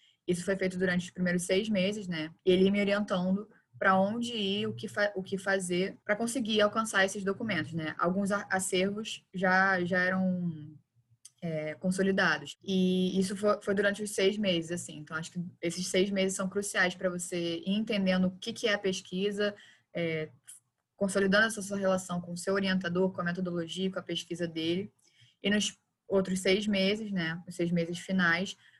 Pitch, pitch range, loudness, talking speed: 190 Hz, 175-200 Hz, -30 LUFS, 180 wpm